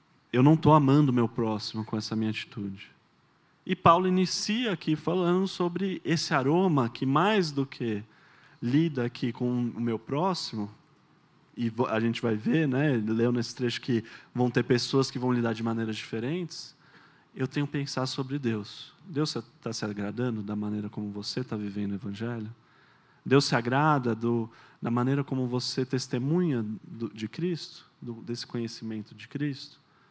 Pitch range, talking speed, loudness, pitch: 115-155 Hz, 165 wpm, -28 LUFS, 125 Hz